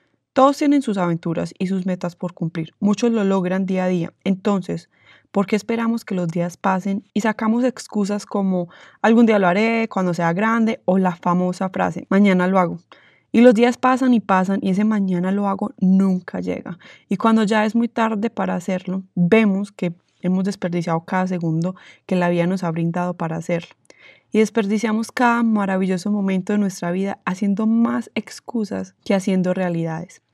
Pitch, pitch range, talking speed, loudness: 195 Hz, 180-220 Hz, 180 wpm, -20 LUFS